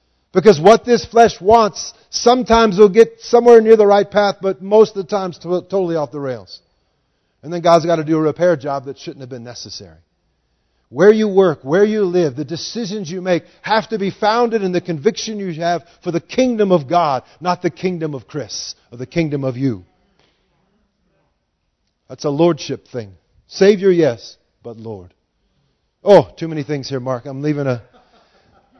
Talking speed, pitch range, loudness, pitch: 180 wpm, 135-205 Hz, -15 LUFS, 175 Hz